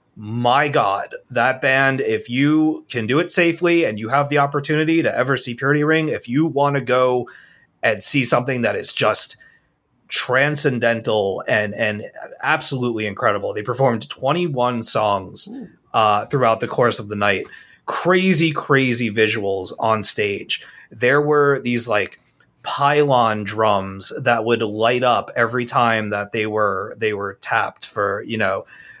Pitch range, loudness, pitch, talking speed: 115-145 Hz, -19 LUFS, 125 Hz, 150 wpm